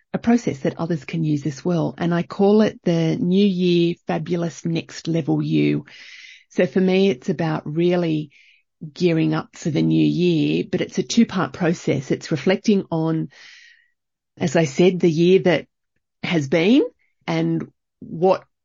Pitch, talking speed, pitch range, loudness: 170 Hz, 160 wpm, 160-190 Hz, -20 LUFS